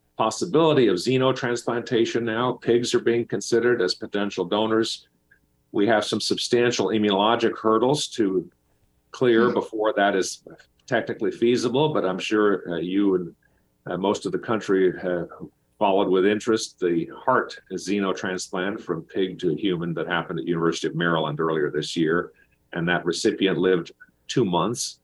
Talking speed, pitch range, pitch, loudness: 145 wpm, 90-120 Hz, 105 Hz, -23 LUFS